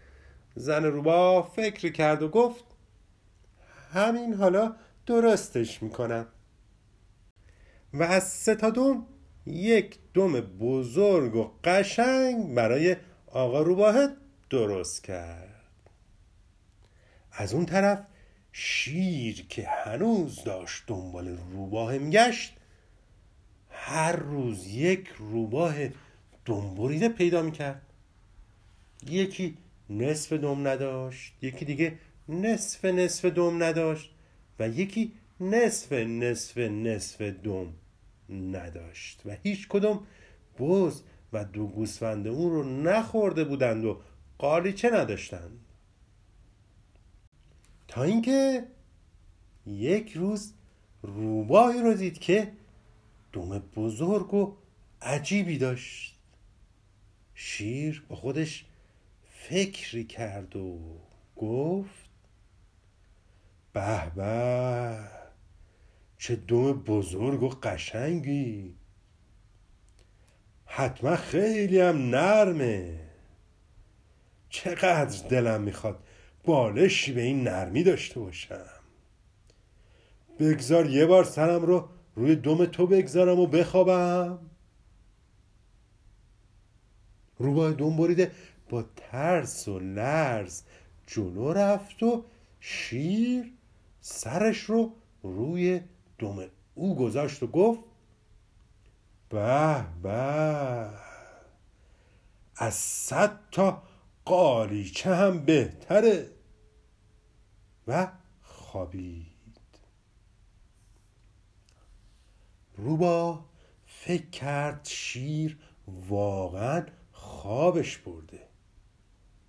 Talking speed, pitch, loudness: 80 wpm, 115 Hz, -27 LUFS